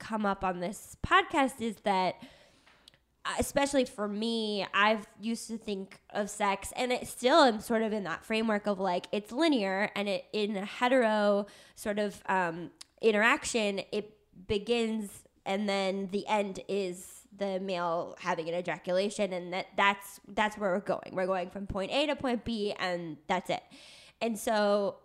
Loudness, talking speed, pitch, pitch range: -31 LUFS, 170 wpm, 205 Hz, 190-225 Hz